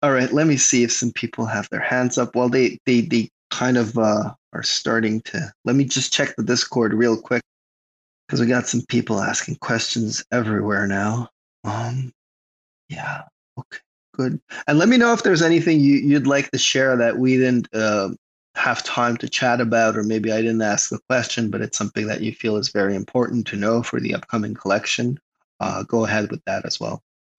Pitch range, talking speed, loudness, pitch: 110-125 Hz, 205 wpm, -20 LUFS, 120 Hz